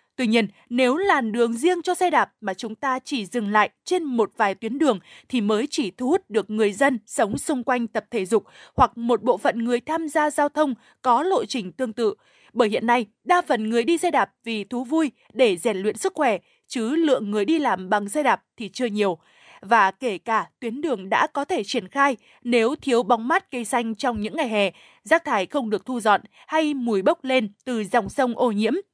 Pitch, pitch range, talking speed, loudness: 245 Hz, 220-295 Hz, 230 wpm, -23 LUFS